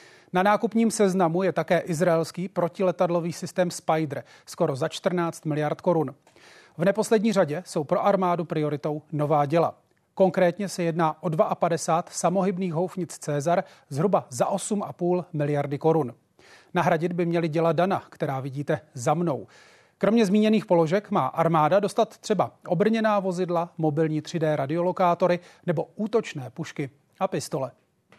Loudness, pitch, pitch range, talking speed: -25 LUFS, 175 Hz, 160-190 Hz, 130 wpm